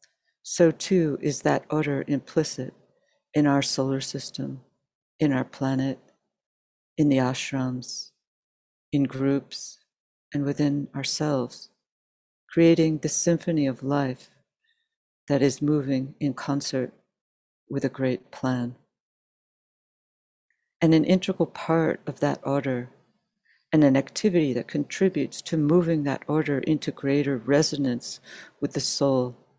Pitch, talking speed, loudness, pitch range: 140 Hz, 115 wpm, -25 LUFS, 130-155 Hz